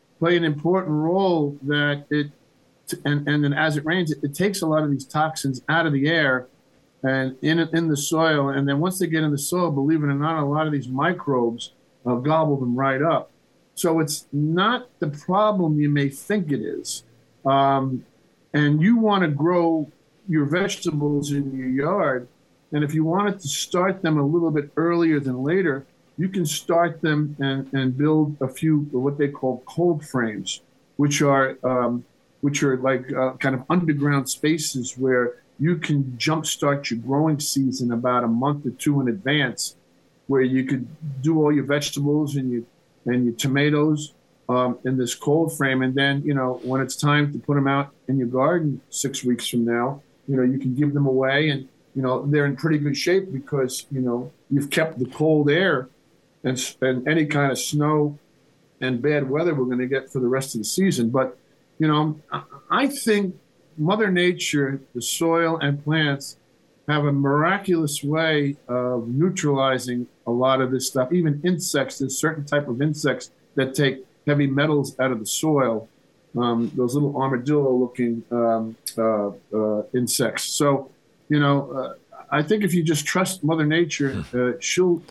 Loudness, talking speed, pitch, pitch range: -22 LUFS, 185 wpm, 145 Hz, 130-155 Hz